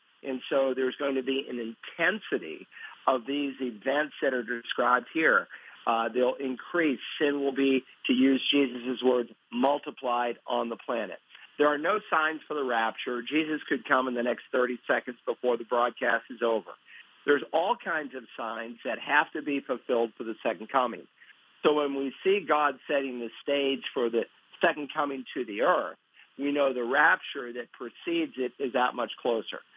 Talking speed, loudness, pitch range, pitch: 180 wpm, -28 LUFS, 120-145 Hz, 130 Hz